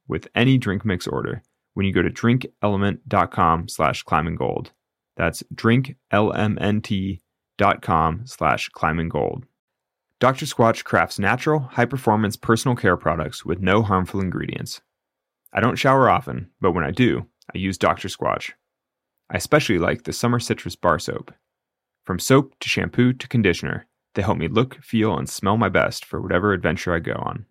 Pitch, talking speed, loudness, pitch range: 110 Hz, 155 wpm, -21 LUFS, 95-120 Hz